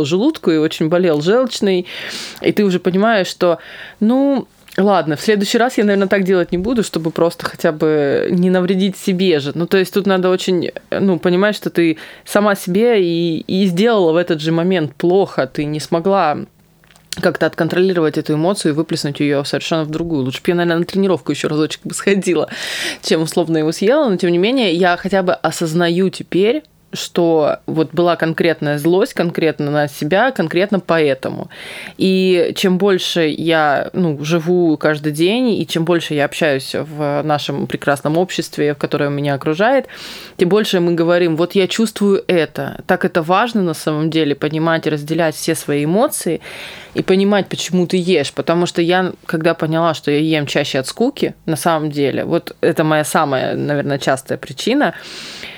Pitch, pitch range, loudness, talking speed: 170 Hz, 155-190 Hz, -16 LUFS, 175 wpm